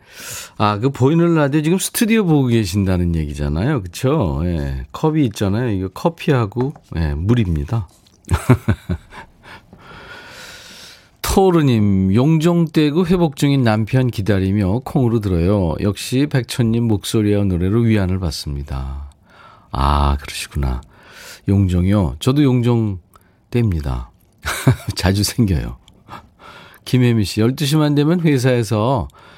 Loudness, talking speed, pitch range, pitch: -17 LUFS, 250 characters per minute, 90-140 Hz, 110 Hz